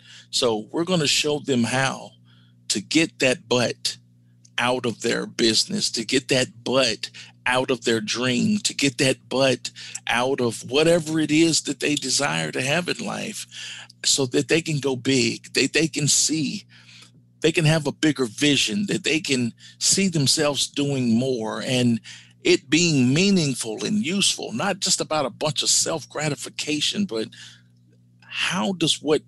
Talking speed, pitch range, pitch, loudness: 165 wpm, 105-155 Hz, 130 Hz, -22 LUFS